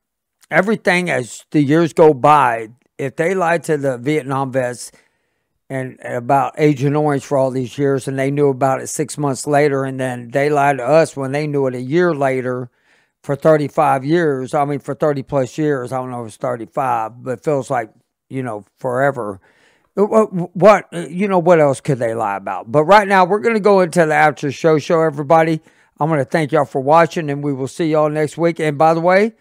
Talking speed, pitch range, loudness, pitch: 205 wpm, 135-165 Hz, -16 LUFS, 145 Hz